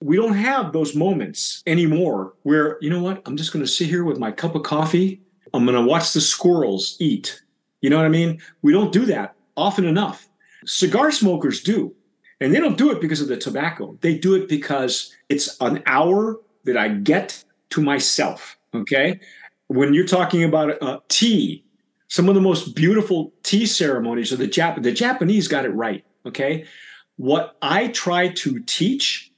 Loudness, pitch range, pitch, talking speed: -20 LUFS, 150-190 Hz, 170 Hz, 185 wpm